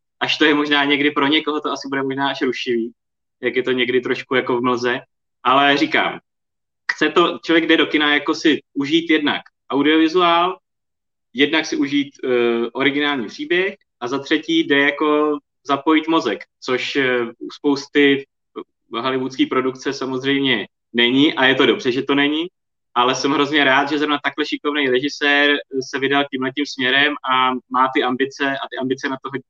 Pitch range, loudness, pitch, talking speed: 130-150 Hz, -18 LUFS, 140 Hz, 165 wpm